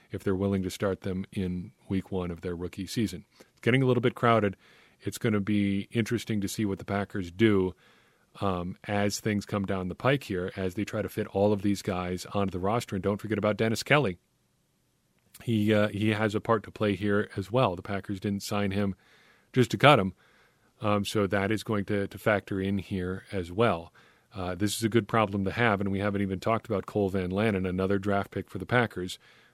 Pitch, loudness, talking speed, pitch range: 100 Hz, -29 LUFS, 225 wpm, 95-110 Hz